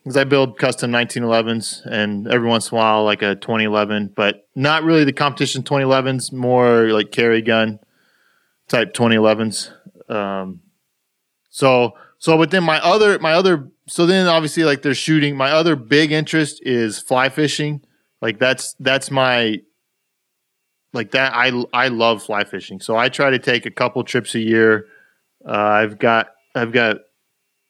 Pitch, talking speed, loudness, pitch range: 125 Hz, 160 wpm, -17 LUFS, 110-145 Hz